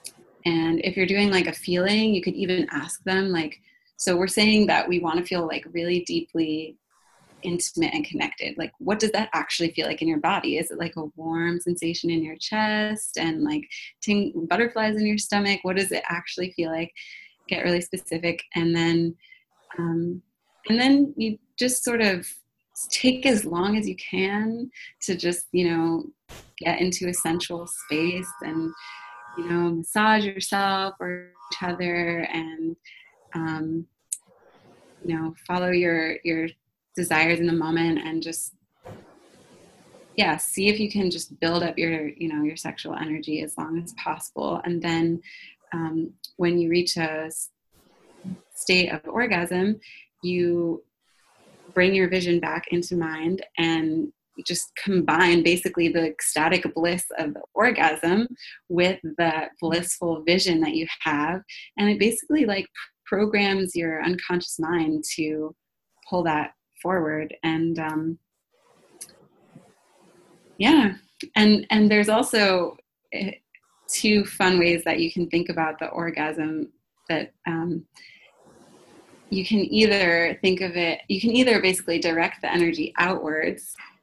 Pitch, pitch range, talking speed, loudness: 175 Hz, 165-195 Hz, 145 wpm, -24 LUFS